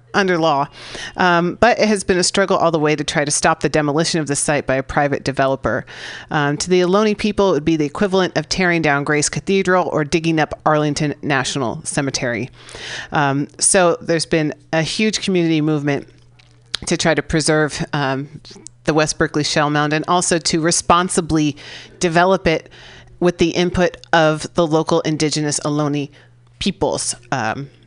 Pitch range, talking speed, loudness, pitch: 145-175 Hz, 170 wpm, -17 LUFS, 155 Hz